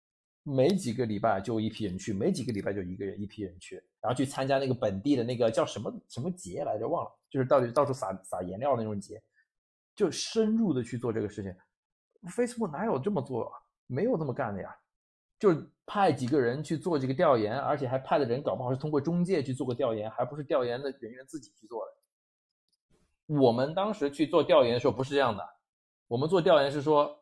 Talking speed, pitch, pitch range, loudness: 345 characters per minute, 130 Hz, 110-150 Hz, -30 LUFS